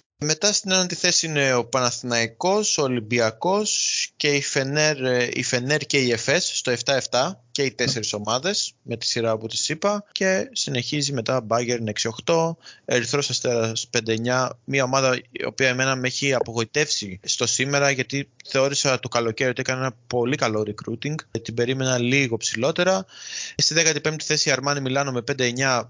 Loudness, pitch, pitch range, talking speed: -22 LUFS, 130 Hz, 120-145 Hz, 160 wpm